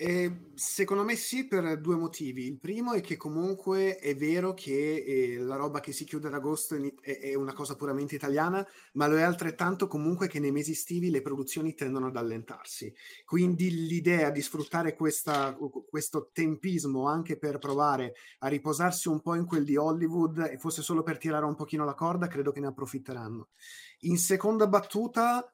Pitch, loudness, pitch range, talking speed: 155 Hz, -31 LUFS, 145-175 Hz, 180 wpm